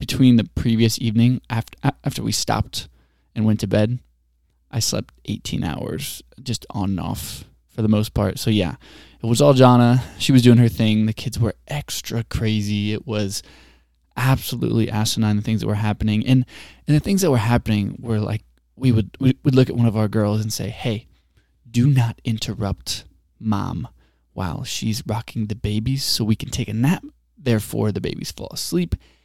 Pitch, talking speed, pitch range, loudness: 110 Hz, 185 wpm, 105-125 Hz, -21 LUFS